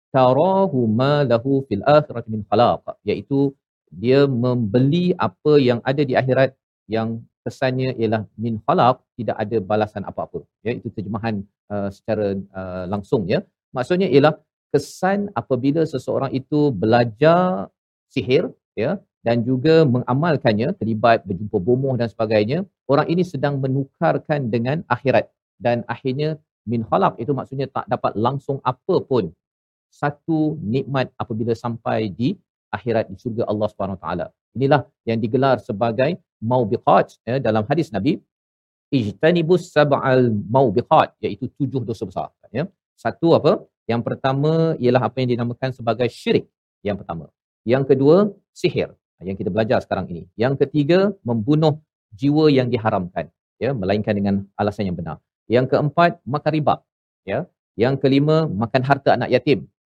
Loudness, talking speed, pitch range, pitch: -20 LUFS, 135 wpm, 115-145 Hz, 130 Hz